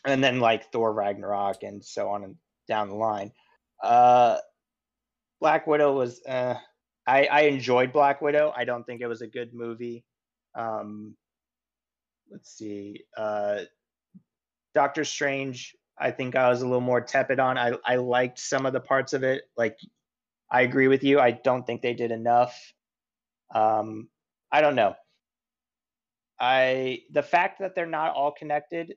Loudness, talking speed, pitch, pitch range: -25 LUFS, 160 wpm, 125 Hz, 115-140 Hz